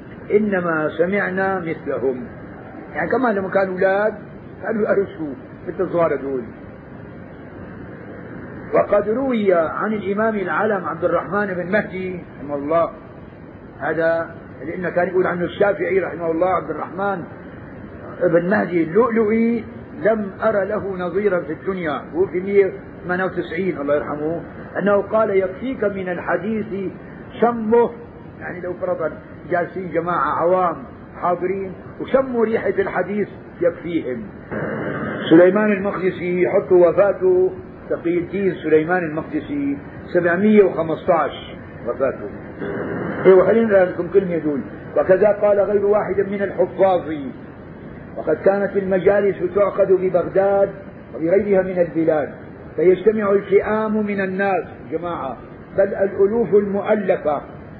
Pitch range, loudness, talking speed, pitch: 175-205 Hz, -19 LUFS, 105 wpm, 190 Hz